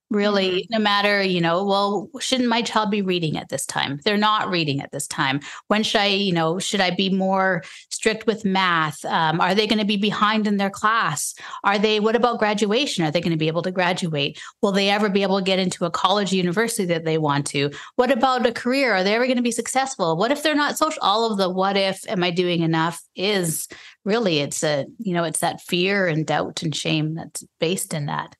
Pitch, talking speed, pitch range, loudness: 195 Hz, 240 wpm, 170-220 Hz, -21 LUFS